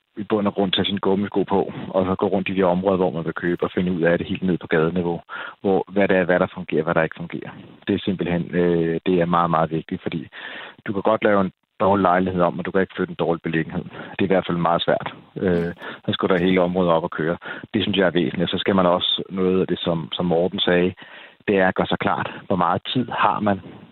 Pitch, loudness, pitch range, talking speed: 90 Hz, -21 LUFS, 85-95 Hz, 270 wpm